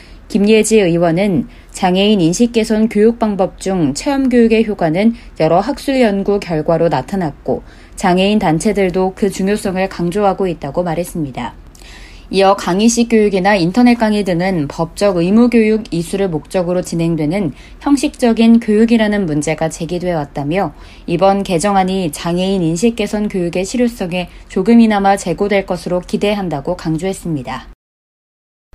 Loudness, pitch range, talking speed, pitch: -14 LUFS, 170-215 Hz, 330 characters per minute, 190 Hz